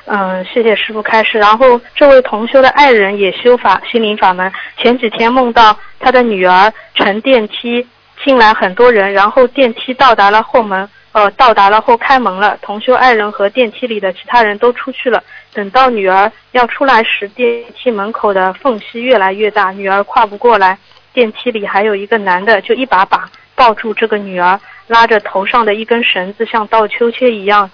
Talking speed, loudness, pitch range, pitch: 285 characters per minute, -10 LUFS, 200-245 Hz, 220 Hz